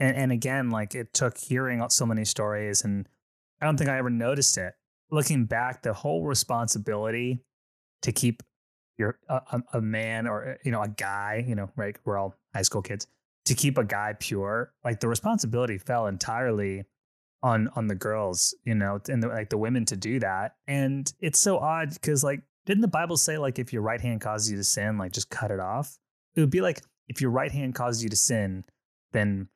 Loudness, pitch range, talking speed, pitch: -27 LUFS, 105-130 Hz, 205 wpm, 120 Hz